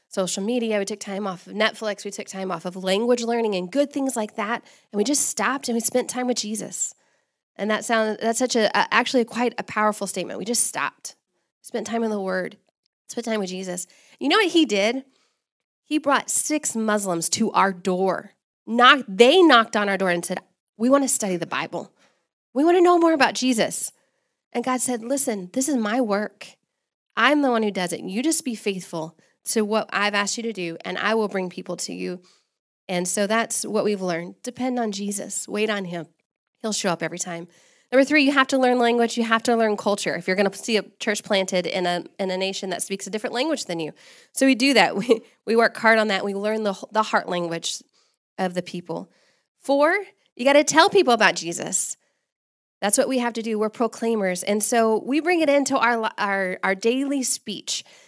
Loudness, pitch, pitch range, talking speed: -22 LUFS, 220 Hz, 195-250 Hz, 220 wpm